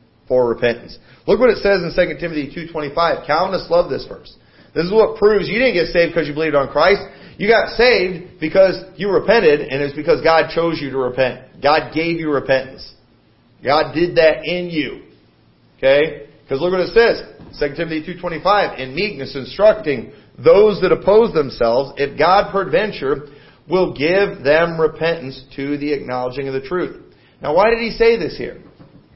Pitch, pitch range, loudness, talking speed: 160 Hz, 140-190 Hz, -17 LUFS, 175 wpm